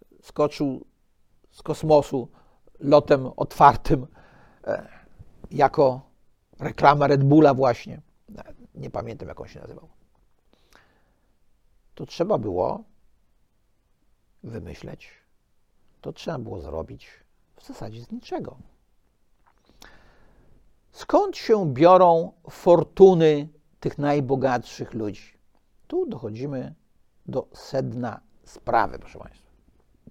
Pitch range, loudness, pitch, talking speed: 130-155 Hz, -22 LUFS, 145 Hz, 85 wpm